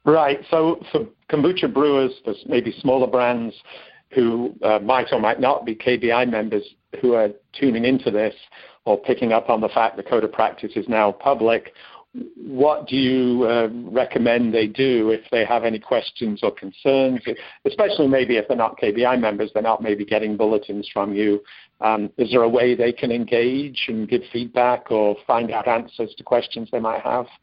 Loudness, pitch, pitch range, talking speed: -20 LUFS, 120 Hz, 110-130 Hz, 185 wpm